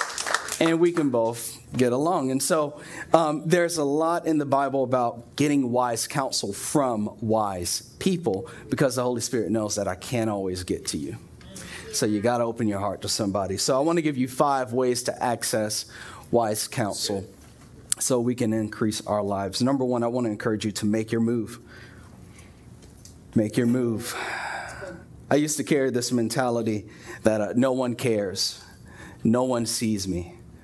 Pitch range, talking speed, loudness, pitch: 110-130 Hz, 175 wpm, -25 LUFS, 120 Hz